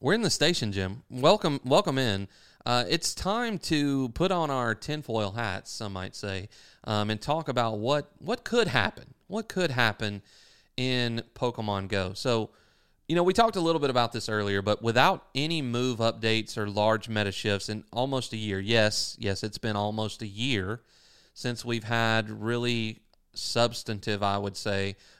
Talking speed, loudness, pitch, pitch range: 175 wpm, -28 LUFS, 115 Hz, 105-135 Hz